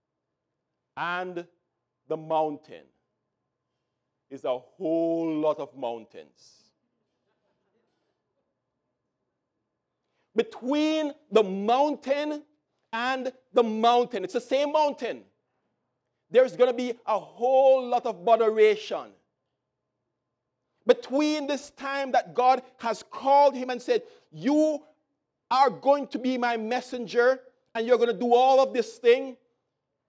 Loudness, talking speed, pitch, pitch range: -25 LUFS, 105 wpm, 245 Hz, 195-275 Hz